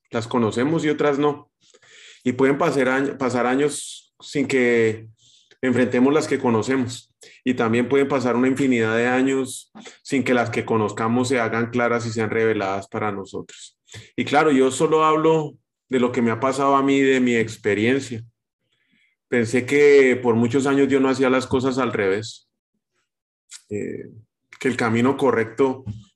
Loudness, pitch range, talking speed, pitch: -20 LUFS, 115-135 Hz, 160 wpm, 125 Hz